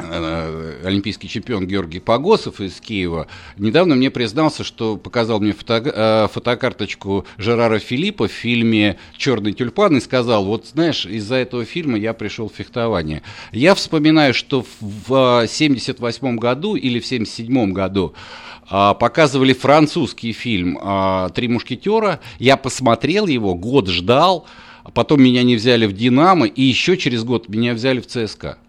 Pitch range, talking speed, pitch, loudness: 100-130 Hz, 135 wpm, 115 Hz, -17 LUFS